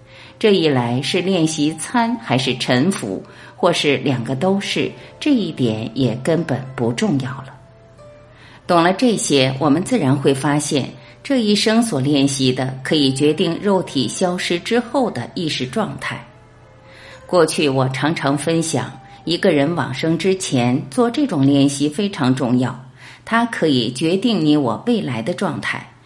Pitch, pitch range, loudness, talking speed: 145 Hz, 130-185 Hz, -18 LUFS, 220 characters per minute